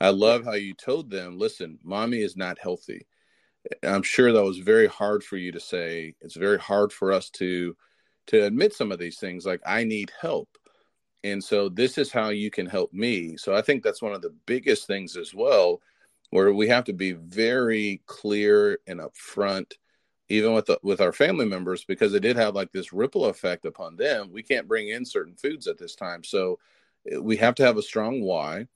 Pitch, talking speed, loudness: 115 Hz, 210 wpm, -25 LUFS